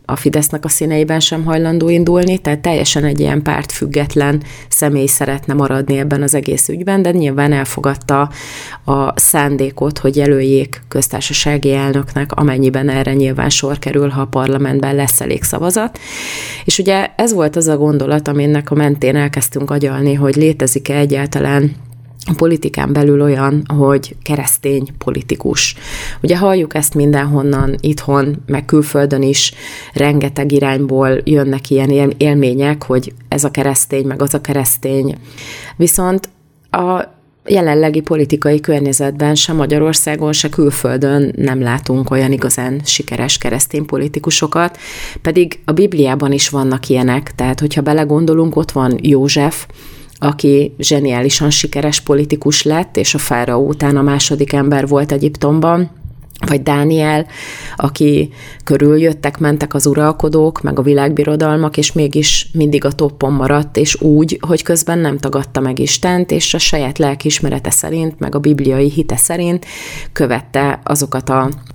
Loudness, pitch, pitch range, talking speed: -13 LUFS, 145 Hz, 140-150 Hz, 135 wpm